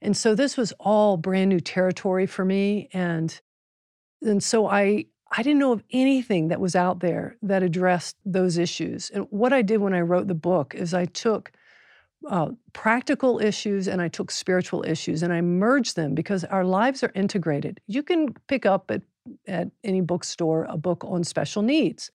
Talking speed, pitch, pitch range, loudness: 185 wpm, 190 Hz, 180-220 Hz, -24 LUFS